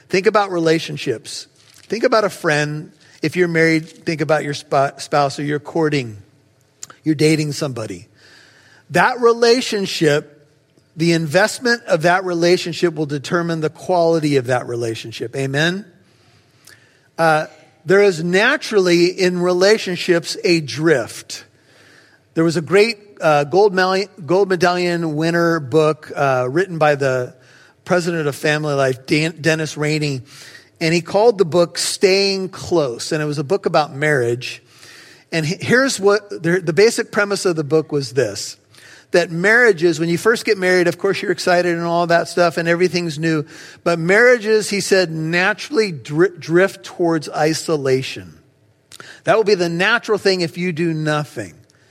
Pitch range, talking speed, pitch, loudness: 150-185 Hz, 150 wpm, 165 Hz, -17 LUFS